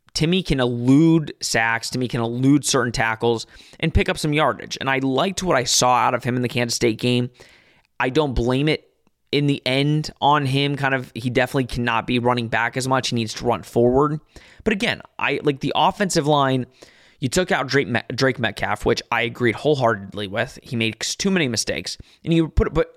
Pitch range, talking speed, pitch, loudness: 120-150 Hz, 210 wpm, 130 Hz, -20 LUFS